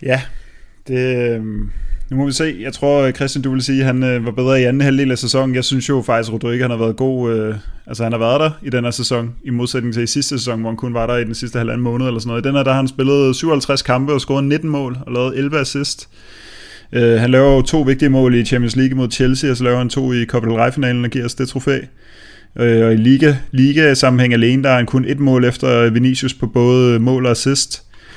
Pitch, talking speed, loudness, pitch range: 125 Hz, 265 wpm, -15 LUFS, 120-135 Hz